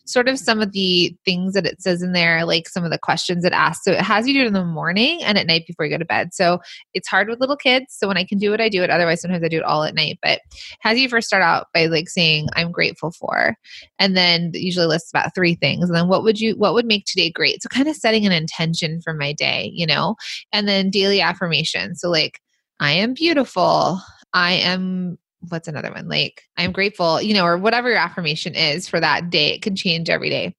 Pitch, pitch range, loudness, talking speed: 180 Hz, 170-205 Hz, -18 LUFS, 255 wpm